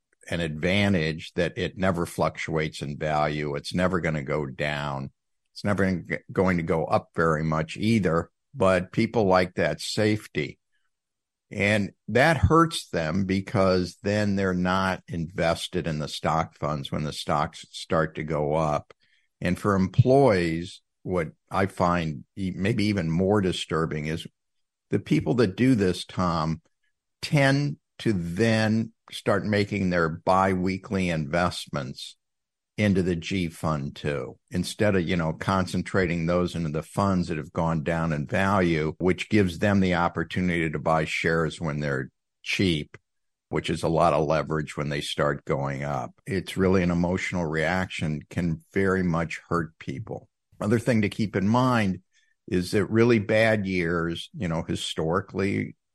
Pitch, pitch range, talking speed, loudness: 90 Hz, 80-100 Hz, 150 wpm, -25 LUFS